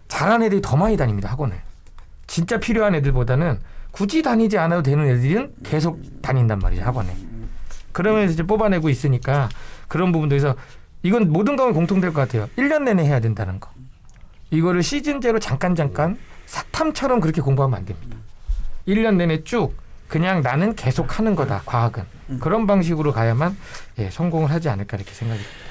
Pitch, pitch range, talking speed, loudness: 145 Hz, 115-195 Hz, 385 characters per minute, -20 LUFS